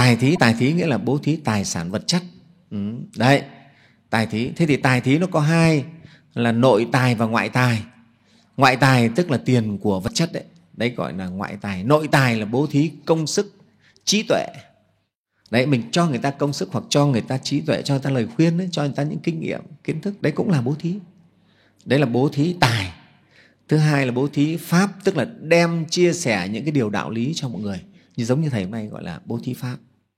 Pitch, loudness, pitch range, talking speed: 140 Hz, -20 LUFS, 120-165 Hz, 235 wpm